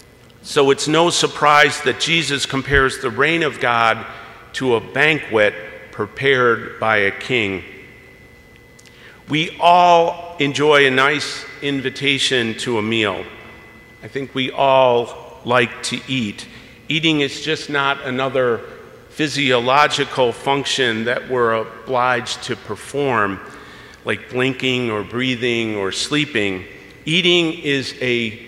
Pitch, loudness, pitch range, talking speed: 130 Hz, -17 LUFS, 115-145 Hz, 115 wpm